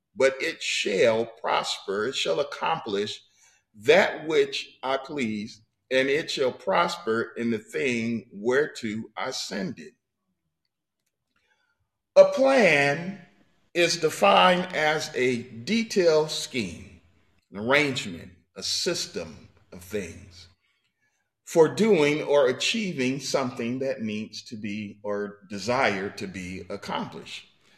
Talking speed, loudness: 110 wpm, -25 LUFS